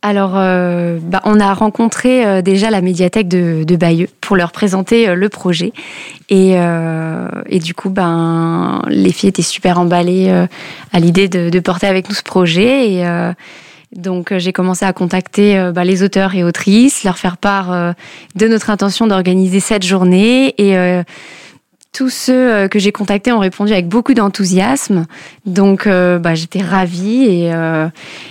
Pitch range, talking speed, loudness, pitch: 180-205 Hz, 175 wpm, -12 LUFS, 190 Hz